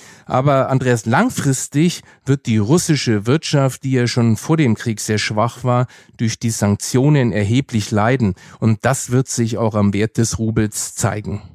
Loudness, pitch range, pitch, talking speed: -17 LUFS, 110-135 Hz, 120 Hz, 160 wpm